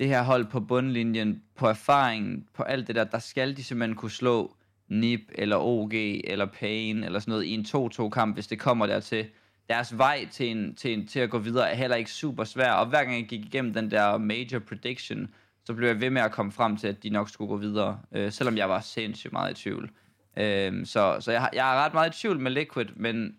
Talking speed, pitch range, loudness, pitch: 245 wpm, 105-125 Hz, -28 LUFS, 115 Hz